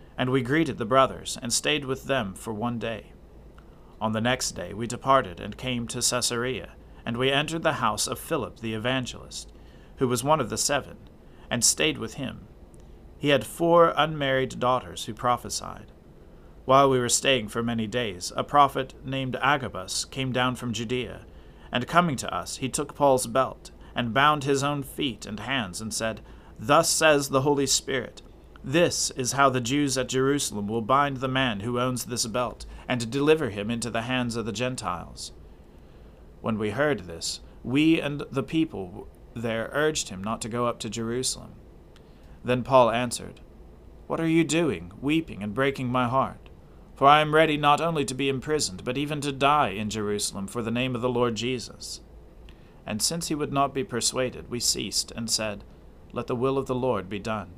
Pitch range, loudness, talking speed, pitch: 105-135 Hz, -25 LUFS, 185 wpm, 125 Hz